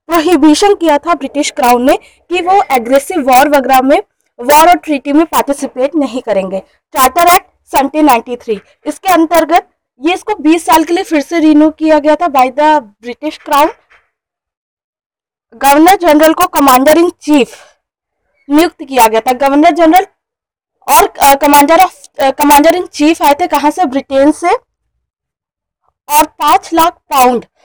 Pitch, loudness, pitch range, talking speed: 305 Hz, -9 LUFS, 275-340 Hz, 145 wpm